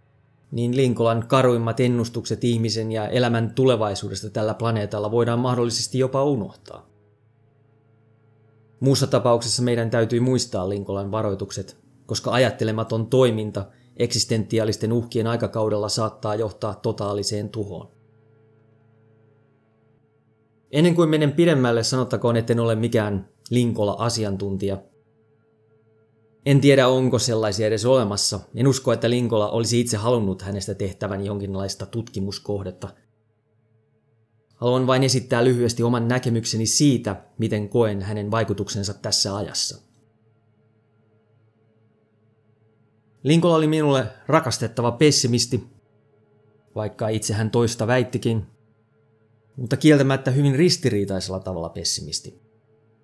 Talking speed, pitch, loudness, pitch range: 95 wpm, 110 Hz, -22 LUFS, 110-120 Hz